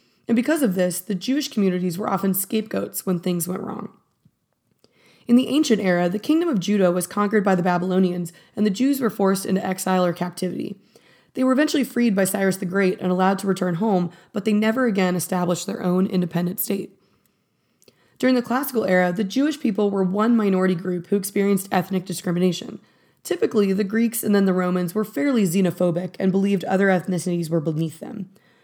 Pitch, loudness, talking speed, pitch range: 195 Hz, -22 LUFS, 190 wpm, 180-215 Hz